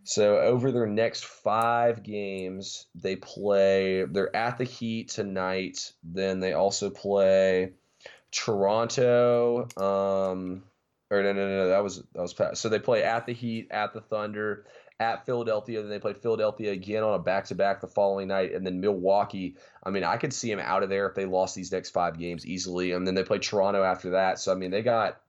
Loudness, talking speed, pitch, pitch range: -27 LUFS, 195 wpm, 100 Hz, 95-110 Hz